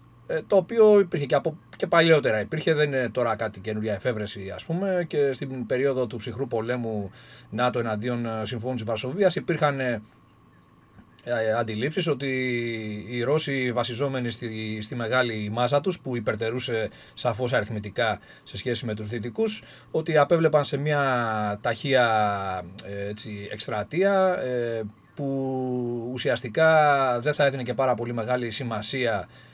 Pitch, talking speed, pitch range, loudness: 125 Hz, 125 wpm, 110-140 Hz, -25 LUFS